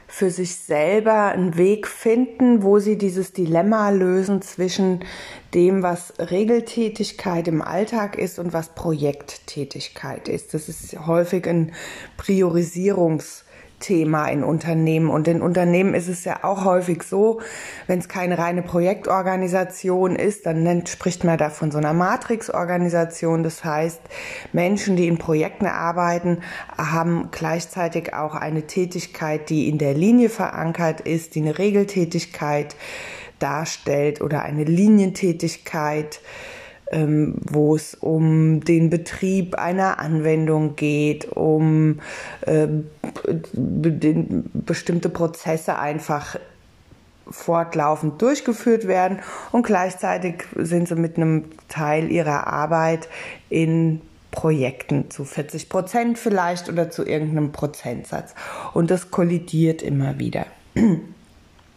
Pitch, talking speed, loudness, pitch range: 170 Hz, 120 wpm, -21 LUFS, 155-190 Hz